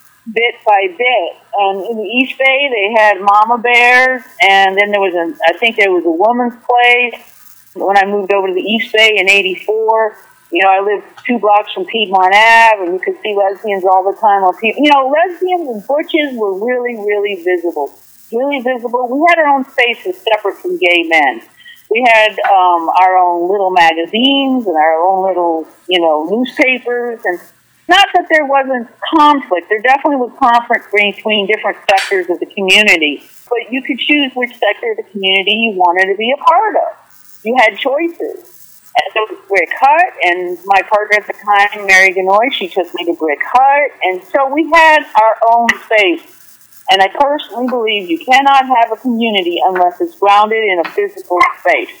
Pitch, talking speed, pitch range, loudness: 220 Hz, 190 wpm, 195-265 Hz, -11 LUFS